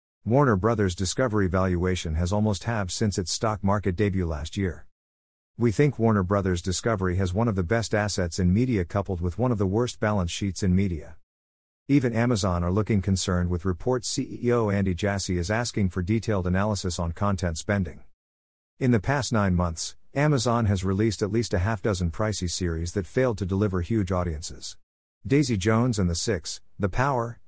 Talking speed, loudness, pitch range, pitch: 180 wpm, -25 LUFS, 90-115 Hz, 100 Hz